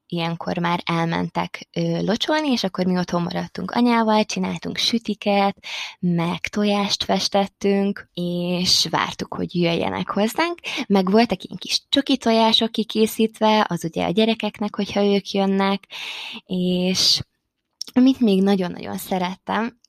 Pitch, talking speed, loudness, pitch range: 200 Hz, 120 wpm, -21 LUFS, 180-225 Hz